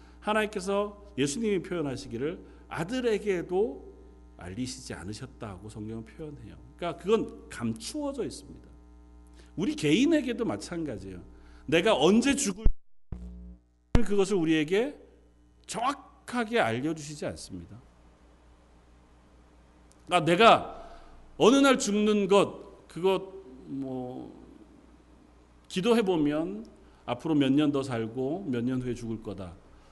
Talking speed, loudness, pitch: 250 characters per minute, -28 LUFS, 130 Hz